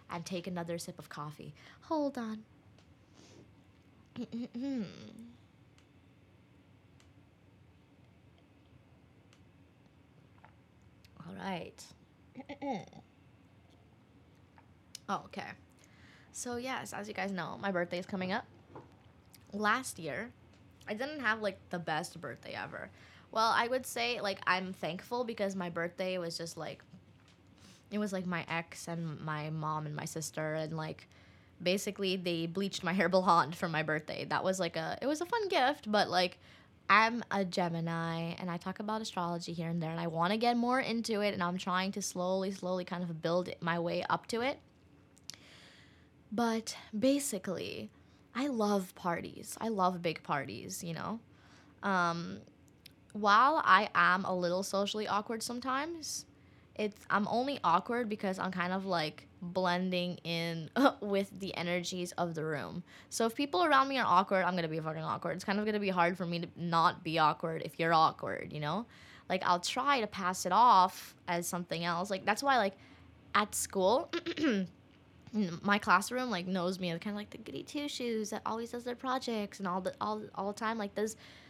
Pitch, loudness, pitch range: 185 Hz, -34 LUFS, 165-215 Hz